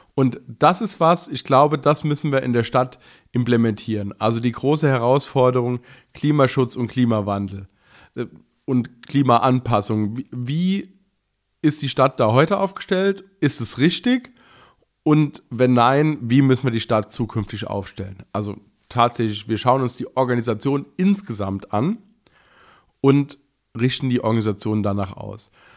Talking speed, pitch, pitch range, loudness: 135 wpm, 125 Hz, 110-145 Hz, -20 LUFS